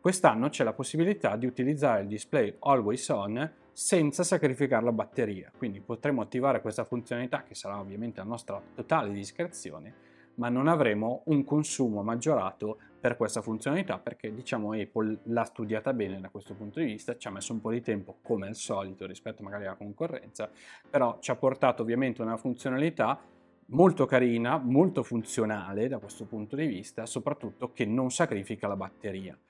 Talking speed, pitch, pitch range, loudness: 165 wpm, 115 Hz, 105-135 Hz, -30 LUFS